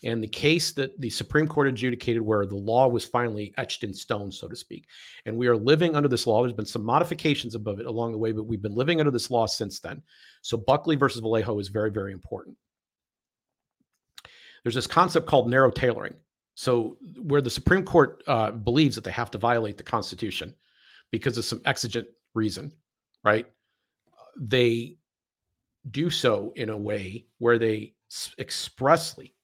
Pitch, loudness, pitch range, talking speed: 120 Hz, -26 LUFS, 110-135 Hz, 175 wpm